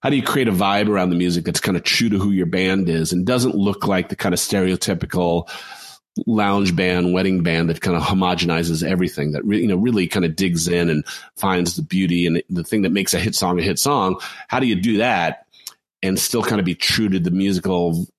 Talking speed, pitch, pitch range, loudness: 240 wpm, 90 Hz, 85-95 Hz, -19 LUFS